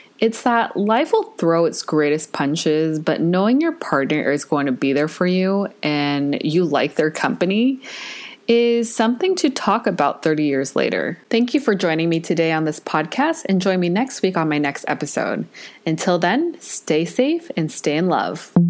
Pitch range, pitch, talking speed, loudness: 155-235 Hz, 175 Hz, 185 wpm, -19 LUFS